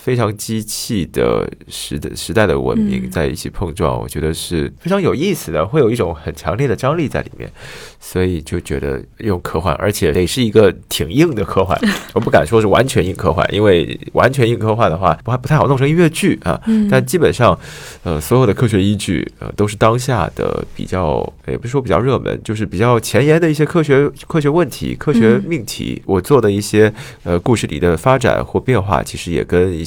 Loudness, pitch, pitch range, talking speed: -15 LUFS, 110 Hz, 90-130 Hz, 315 characters per minute